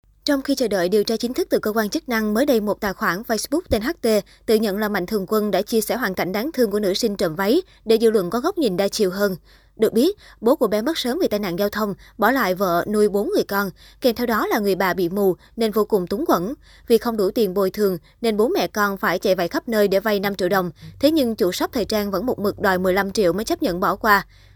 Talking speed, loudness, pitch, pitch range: 285 wpm, -21 LUFS, 210 Hz, 195-235 Hz